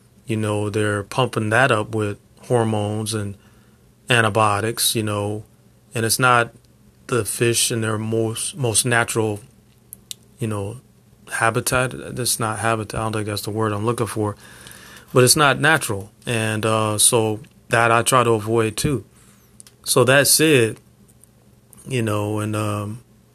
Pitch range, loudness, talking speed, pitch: 105-115 Hz, -19 LUFS, 145 wpm, 110 Hz